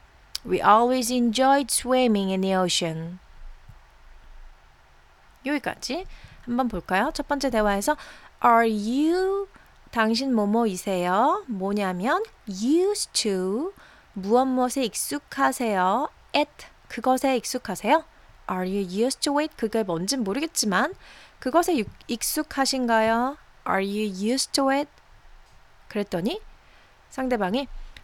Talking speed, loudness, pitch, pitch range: 90 wpm, -24 LUFS, 235 Hz, 195-275 Hz